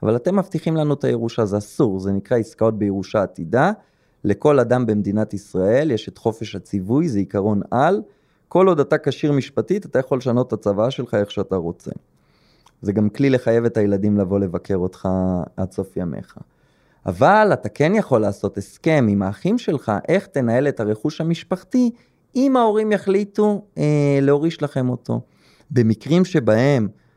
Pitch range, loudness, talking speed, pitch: 100-155 Hz, -20 LUFS, 160 wpm, 120 Hz